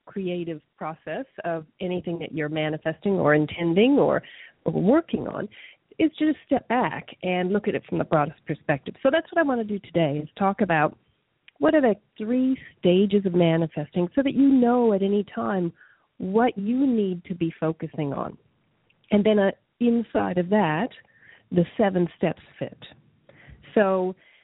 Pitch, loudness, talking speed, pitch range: 190 Hz, -24 LUFS, 165 wpm, 165-230 Hz